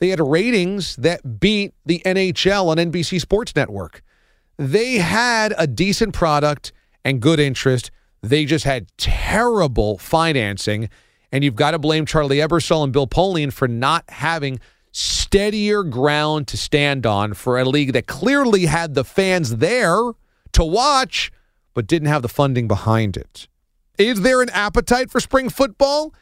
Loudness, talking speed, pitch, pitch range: -18 LUFS, 155 wpm, 160 Hz, 135-195 Hz